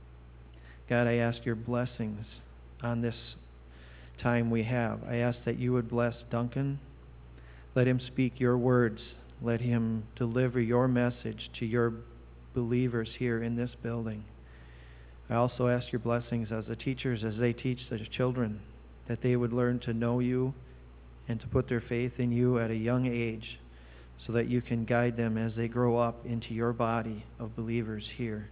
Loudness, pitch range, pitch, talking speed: -31 LUFS, 110-120 Hz, 115 Hz, 170 wpm